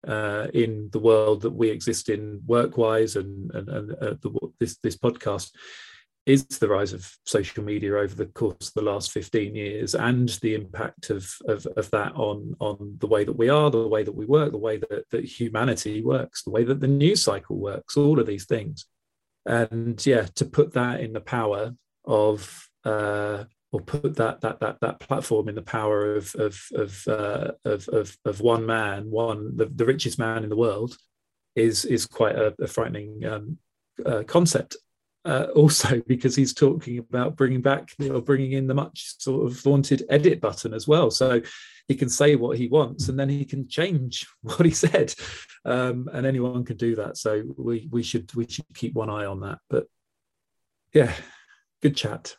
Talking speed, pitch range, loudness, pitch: 195 wpm, 110-135 Hz, -24 LUFS, 115 Hz